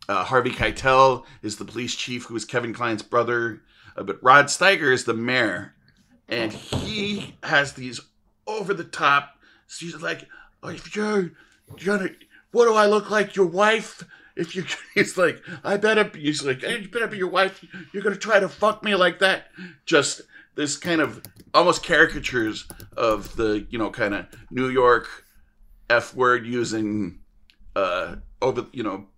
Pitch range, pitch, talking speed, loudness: 120-195 Hz, 145 Hz, 170 wpm, -22 LUFS